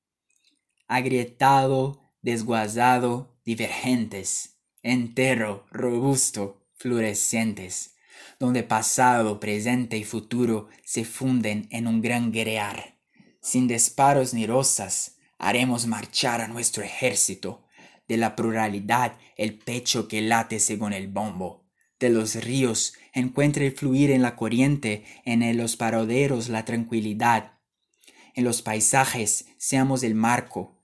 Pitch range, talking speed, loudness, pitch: 110-125 Hz, 110 wpm, -24 LUFS, 115 Hz